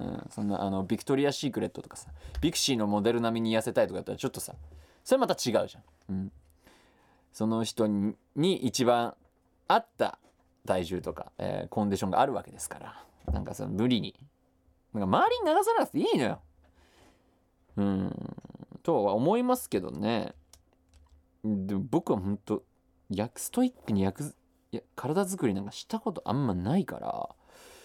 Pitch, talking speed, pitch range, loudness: 105 Hz, 335 characters per minute, 85-145 Hz, -30 LUFS